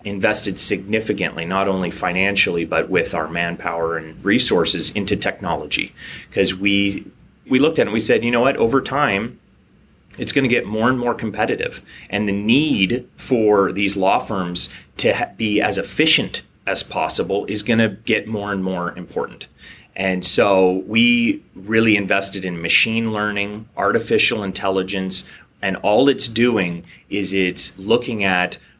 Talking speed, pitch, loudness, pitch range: 155 wpm, 100 Hz, -19 LUFS, 95-110 Hz